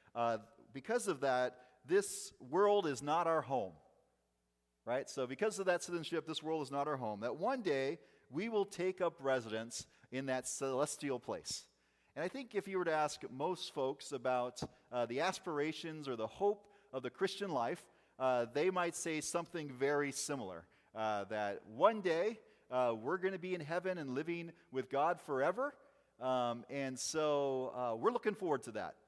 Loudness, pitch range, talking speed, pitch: -38 LUFS, 125-180 Hz, 180 wpm, 145 Hz